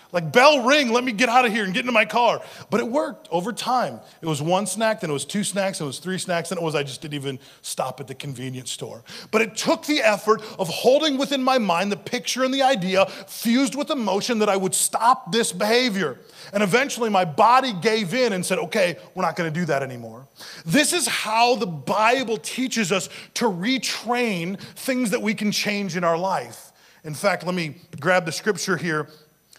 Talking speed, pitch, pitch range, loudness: 220 wpm, 205 Hz, 170-245 Hz, -22 LUFS